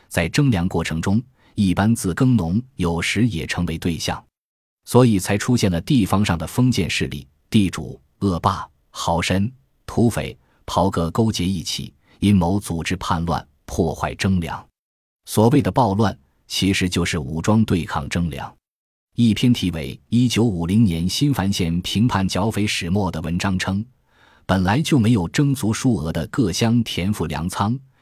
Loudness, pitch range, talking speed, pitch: -20 LUFS, 85-115 Hz, 235 characters per minute, 95 Hz